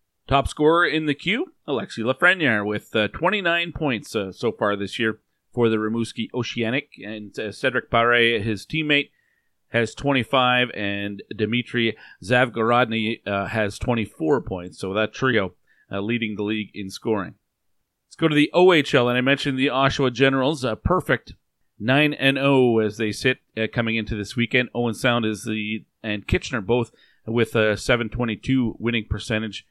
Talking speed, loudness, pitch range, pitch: 160 wpm, -22 LUFS, 110-135 Hz, 115 Hz